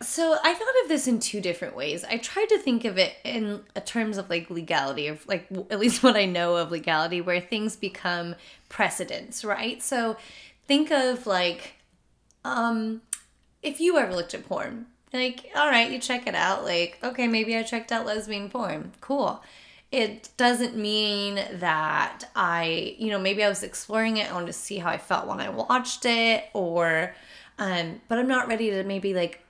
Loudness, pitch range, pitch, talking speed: -26 LUFS, 180-245 Hz, 220 Hz, 190 wpm